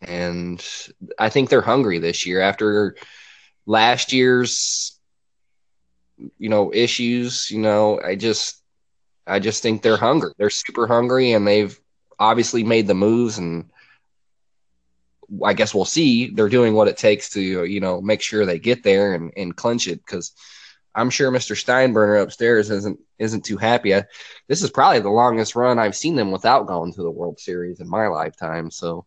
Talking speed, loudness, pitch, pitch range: 170 wpm, -19 LUFS, 105 Hz, 90-120 Hz